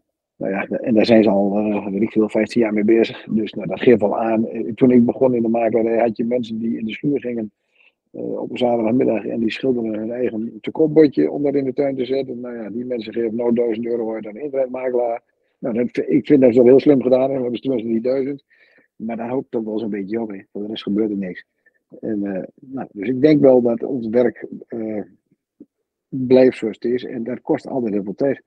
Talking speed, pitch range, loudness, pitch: 240 wpm, 110-130 Hz, -19 LUFS, 115 Hz